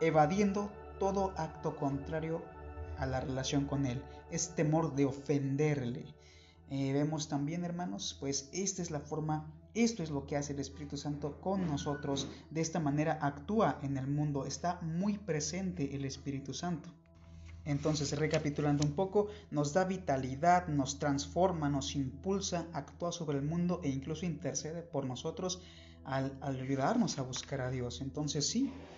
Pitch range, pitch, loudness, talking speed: 135-170 Hz, 145 Hz, -35 LUFS, 155 wpm